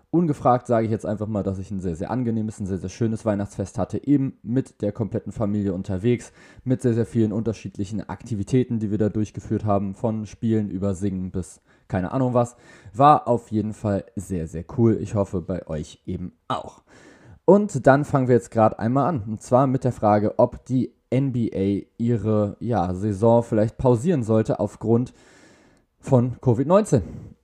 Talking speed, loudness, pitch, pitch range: 175 wpm, -23 LUFS, 110 Hz, 100-120 Hz